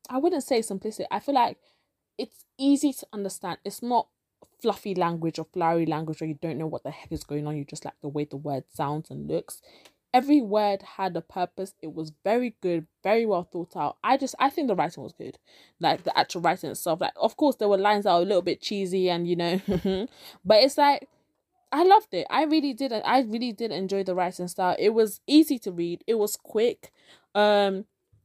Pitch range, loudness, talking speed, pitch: 170-250 Hz, -26 LUFS, 220 wpm, 195 Hz